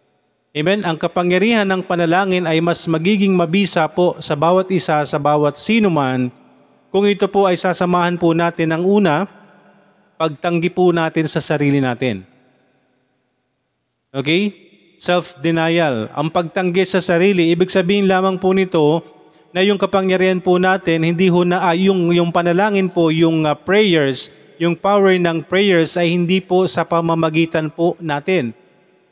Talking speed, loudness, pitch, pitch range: 145 wpm, -16 LUFS, 175 Hz, 160-185 Hz